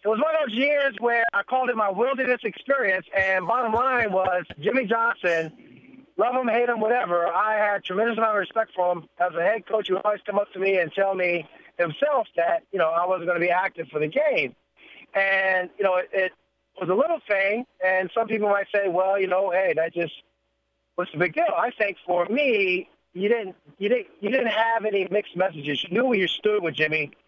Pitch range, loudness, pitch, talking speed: 180-235 Hz, -24 LUFS, 200 Hz, 230 wpm